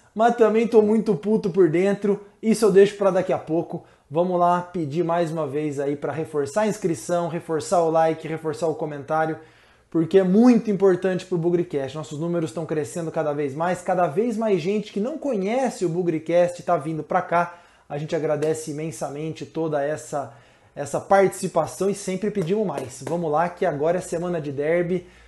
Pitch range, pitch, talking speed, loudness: 155-195 Hz, 170 Hz, 185 wpm, -23 LUFS